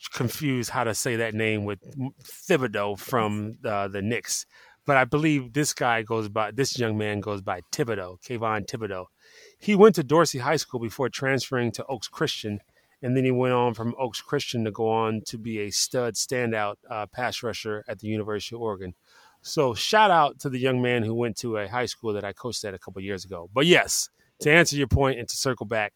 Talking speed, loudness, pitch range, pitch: 215 wpm, -25 LUFS, 105-135 Hz, 120 Hz